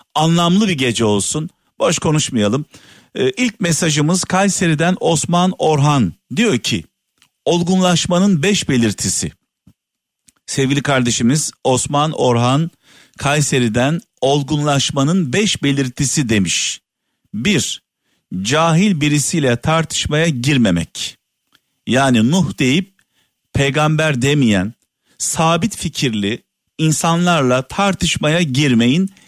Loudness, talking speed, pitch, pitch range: -16 LUFS, 80 wpm, 150 Hz, 130-175 Hz